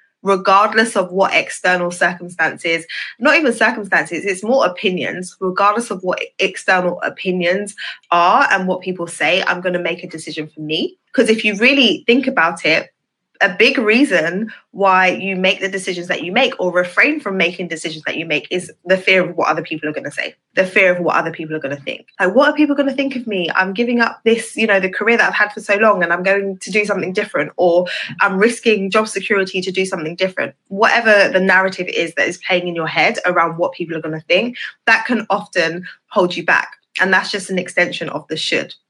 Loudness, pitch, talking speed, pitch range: -16 LUFS, 190 Hz, 225 wpm, 175-215 Hz